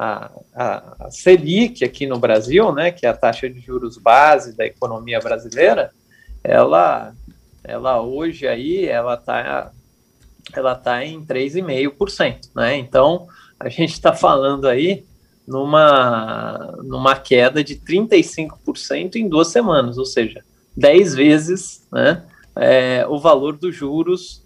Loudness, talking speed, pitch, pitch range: -16 LUFS, 130 wpm, 150 Hz, 130-185 Hz